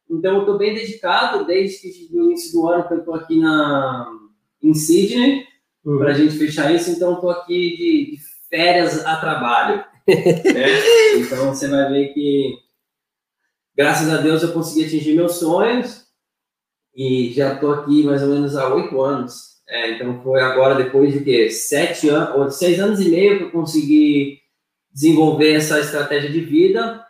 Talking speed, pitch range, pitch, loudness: 165 wpm, 140-195 Hz, 155 Hz, -17 LUFS